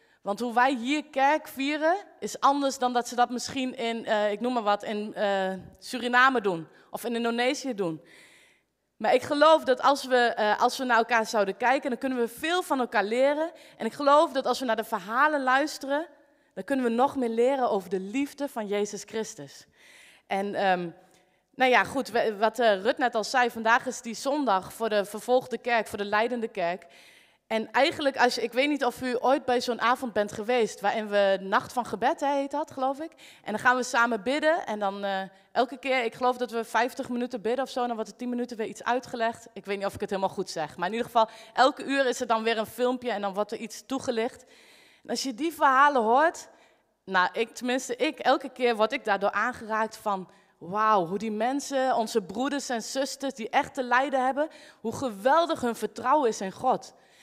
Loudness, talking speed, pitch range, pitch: -27 LUFS, 220 wpm, 215-265 Hz, 240 Hz